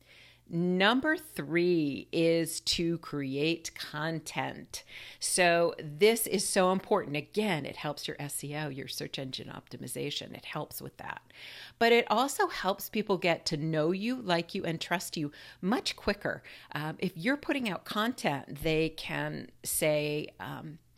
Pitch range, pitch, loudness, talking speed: 150-195 Hz, 165 Hz, -31 LUFS, 145 wpm